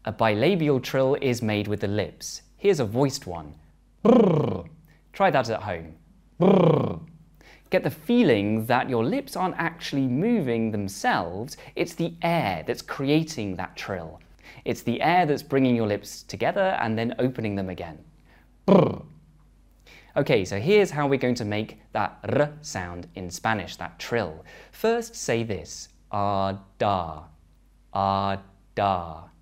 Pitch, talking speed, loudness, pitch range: 110 Hz, 145 wpm, -25 LUFS, 95-150 Hz